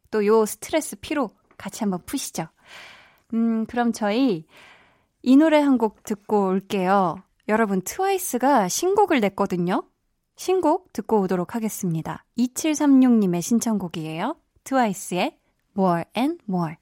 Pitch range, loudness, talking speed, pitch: 190-270 Hz, -22 LUFS, 290 characters per minute, 220 Hz